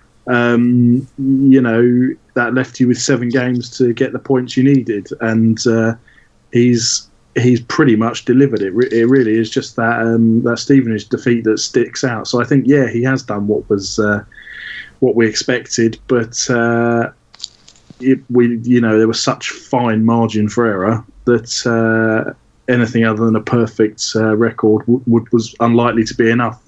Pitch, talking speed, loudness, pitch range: 120 Hz, 175 wpm, -14 LUFS, 115-125 Hz